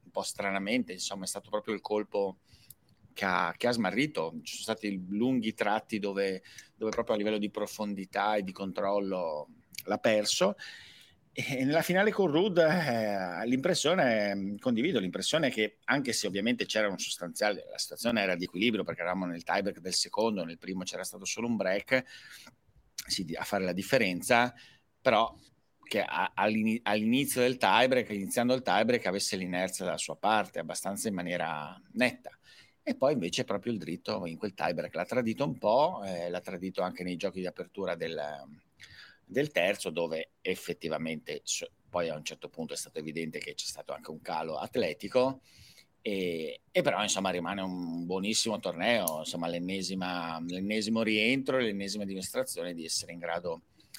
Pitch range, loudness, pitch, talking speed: 90-110 Hz, -31 LUFS, 100 Hz, 160 wpm